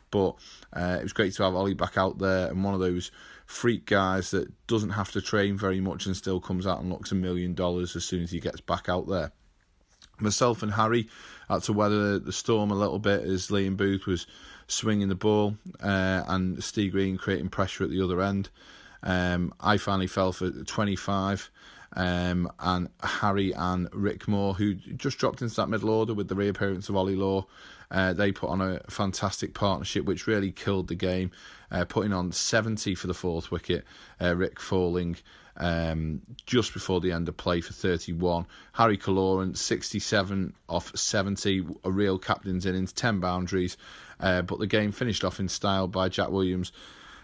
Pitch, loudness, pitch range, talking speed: 95 Hz, -28 LUFS, 90-100 Hz, 190 wpm